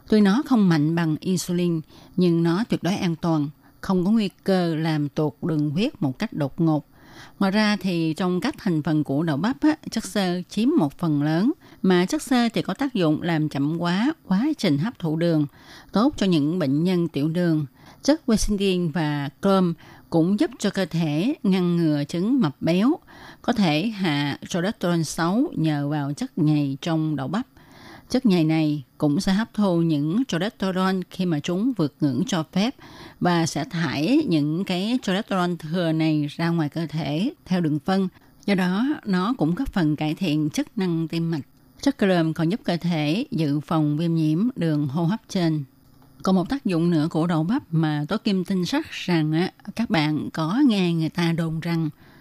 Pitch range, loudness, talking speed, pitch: 155-200 Hz, -23 LUFS, 190 wpm, 170 Hz